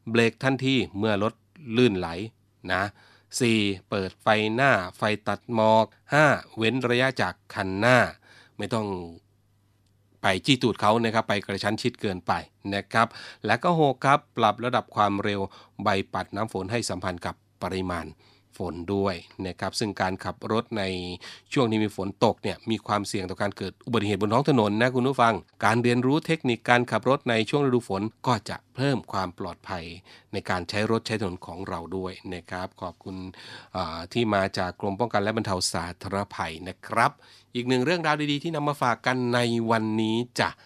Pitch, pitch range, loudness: 105 Hz, 95-120 Hz, -26 LUFS